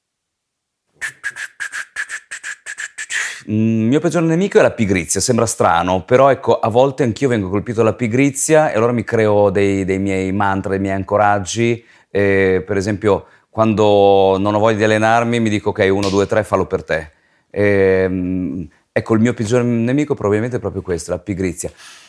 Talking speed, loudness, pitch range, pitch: 160 wpm, -16 LUFS, 100-125 Hz, 110 Hz